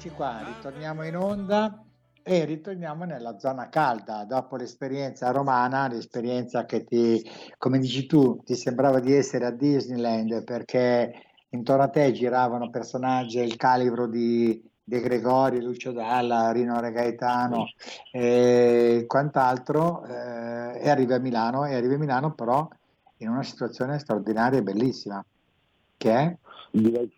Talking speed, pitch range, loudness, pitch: 130 wpm, 120-135 Hz, -25 LUFS, 125 Hz